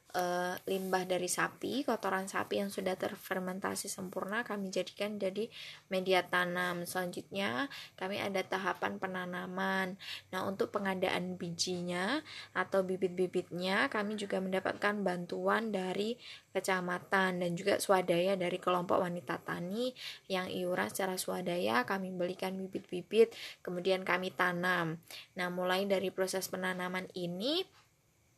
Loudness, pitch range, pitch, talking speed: -35 LUFS, 180-195 Hz, 185 Hz, 115 wpm